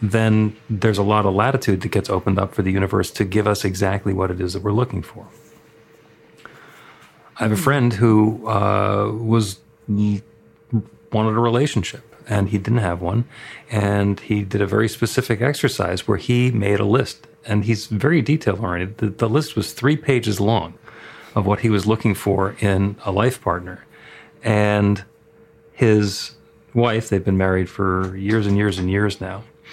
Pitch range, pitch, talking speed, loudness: 100-115 Hz, 105 Hz, 175 wpm, -20 LUFS